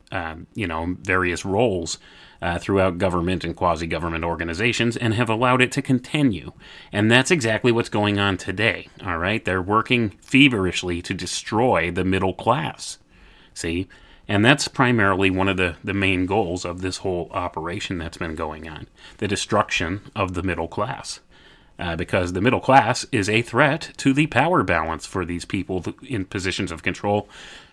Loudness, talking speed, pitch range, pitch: -22 LUFS, 170 wpm, 90-115 Hz, 95 Hz